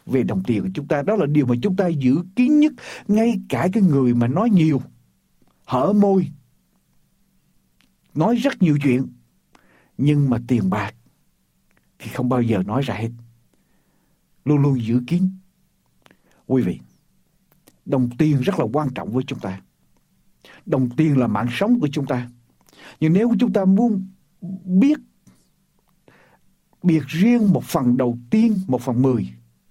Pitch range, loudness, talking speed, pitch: 125-190 Hz, -20 LUFS, 155 wpm, 145 Hz